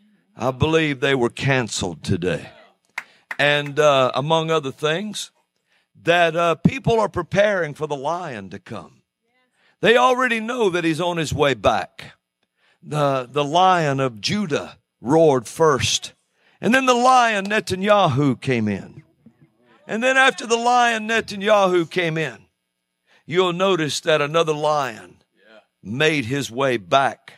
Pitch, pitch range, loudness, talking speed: 155 Hz, 135-200 Hz, -19 LUFS, 135 wpm